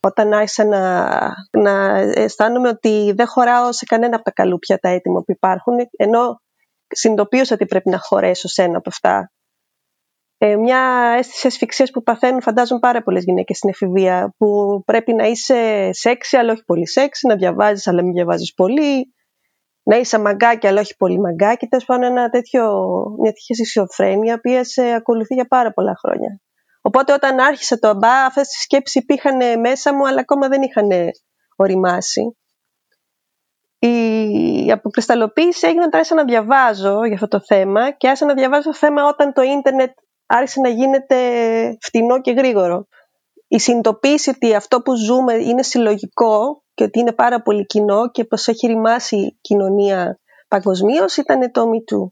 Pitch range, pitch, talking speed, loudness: 210-260 Hz, 235 Hz, 160 wpm, -15 LUFS